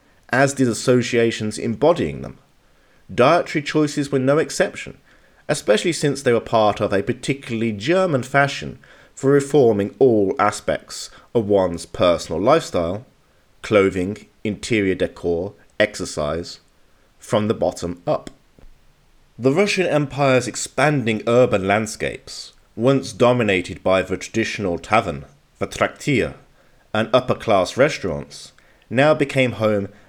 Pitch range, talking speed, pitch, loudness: 100-135 Hz, 115 wpm, 115 Hz, -19 LUFS